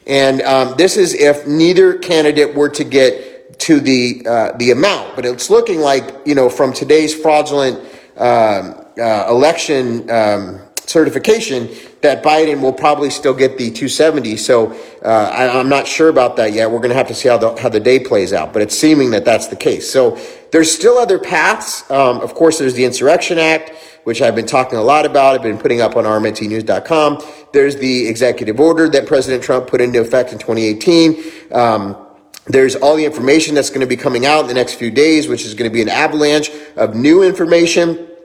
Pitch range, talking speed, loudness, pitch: 125-160 Hz, 200 wpm, -13 LUFS, 145 Hz